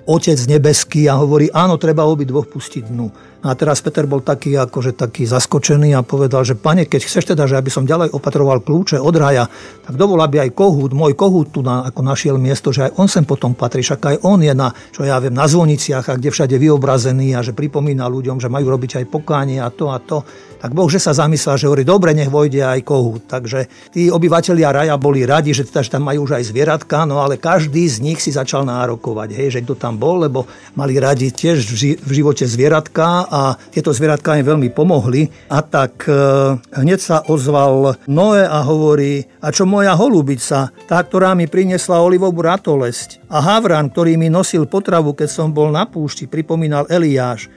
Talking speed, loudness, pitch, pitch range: 200 wpm, -14 LUFS, 145 Hz, 135-160 Hz